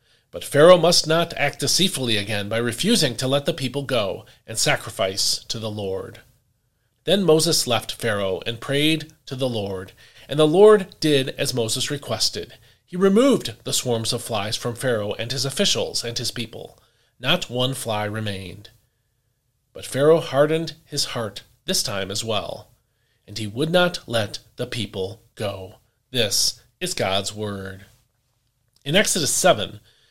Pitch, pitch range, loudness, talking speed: 120 Hz, 110-145 Hz, -21 LUFS, 155 wpm